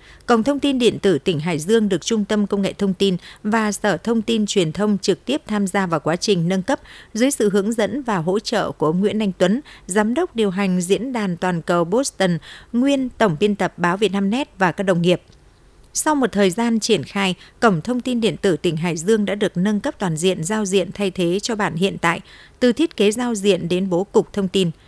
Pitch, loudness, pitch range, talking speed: 200 Hz, -20 LUFS, 185-225 Hz, 245 wpm